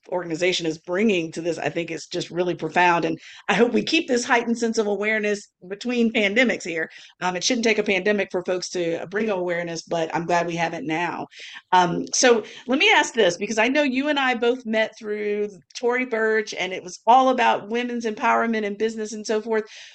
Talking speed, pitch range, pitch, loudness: 215 wpm, 175-230 Hz, 210 Hz, -22 LUFS